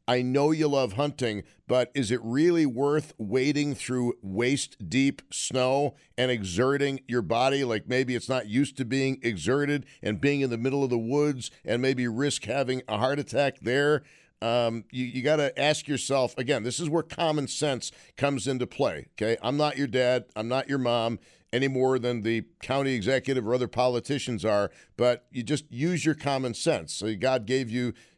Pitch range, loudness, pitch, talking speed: 120-140 Hz, -27 LUFS, 130 Hz, 190 wpm